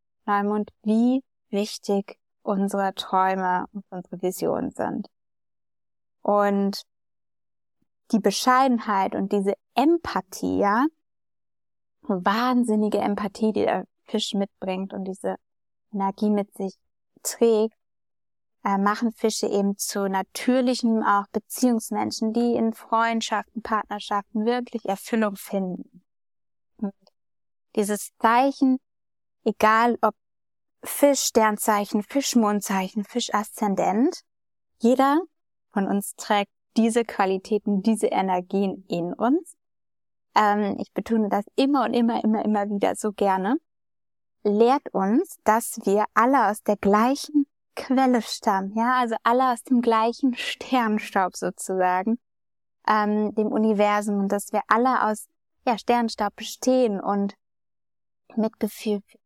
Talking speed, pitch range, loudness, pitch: 110 wpm, 200-235 Hz, -24 LUFS, 215 Hz